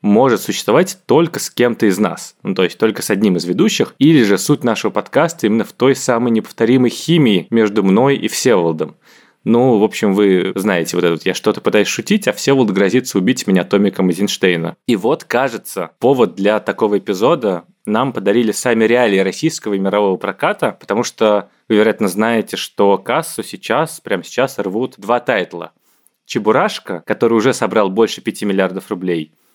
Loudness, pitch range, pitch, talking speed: -15 LUFS, 95-120 Hz, 105 Hz, 175 wpm